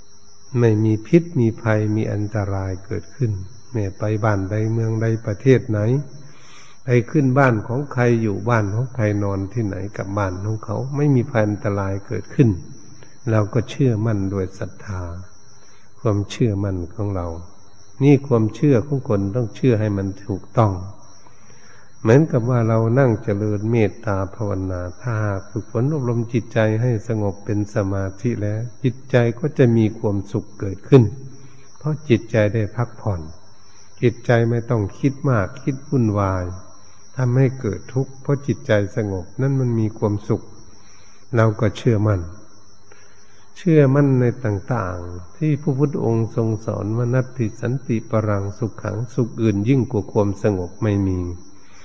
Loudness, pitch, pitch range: -20 LUFS, 110 Hz, 100-125 Hz